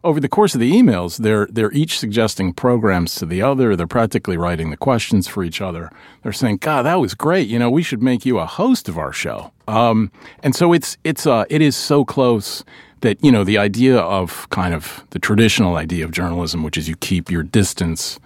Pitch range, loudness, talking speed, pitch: 90-135 Hz, -17 LUFS, 225 wpm, 110 Hz